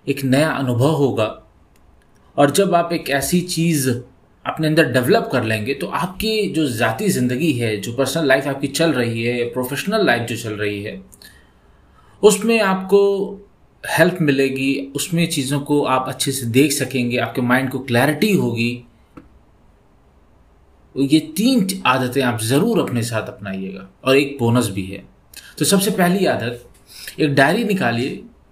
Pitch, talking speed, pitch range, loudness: 135 Hz, 150 wpm, 120-160 Hz, -18 LUFS